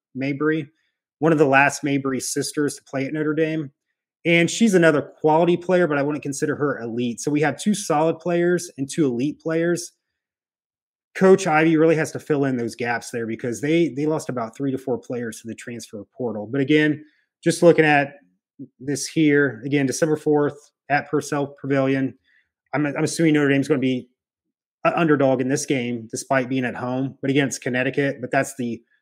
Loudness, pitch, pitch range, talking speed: -21 LUFS, 145 Hz, 130-155 Hz, 190 wpm